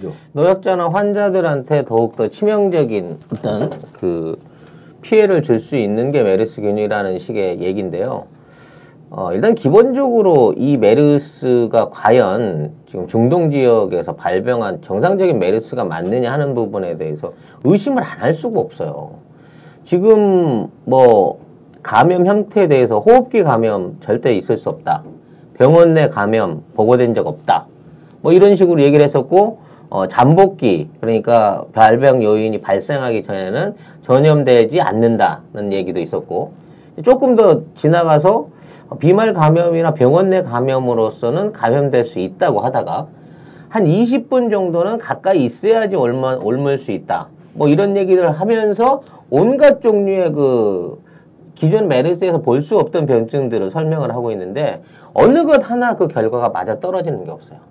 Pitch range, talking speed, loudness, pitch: 120-195 Hz, 295 characters per minute, -14 LUFS, 155 Hz